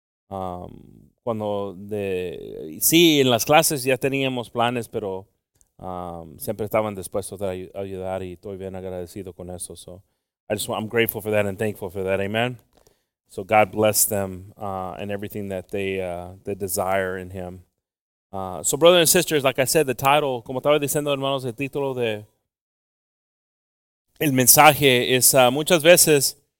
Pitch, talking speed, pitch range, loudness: 105 Hz, 165 wpm, 95-135 Hz, -20 LUFS